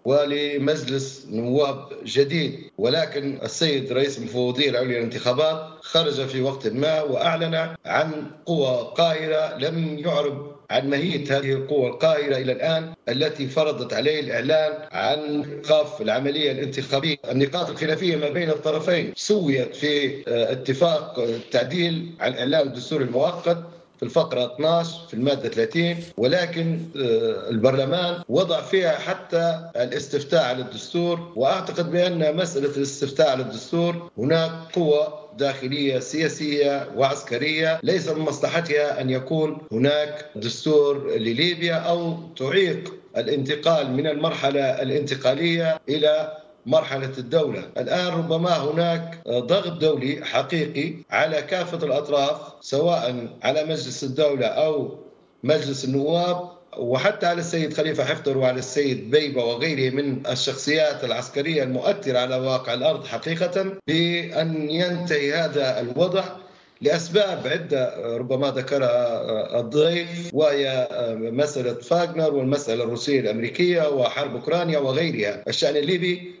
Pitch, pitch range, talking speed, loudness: 150 Hz, 135-165 Hz, 110 wpm, -23 LUFS